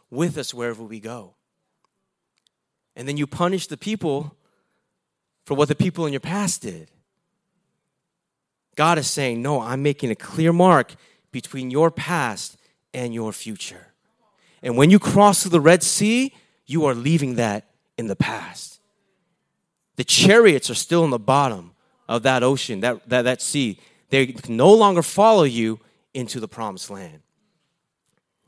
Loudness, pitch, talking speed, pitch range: -19 LUFS, 145 Hz, 155 wpm, 125-170 Hz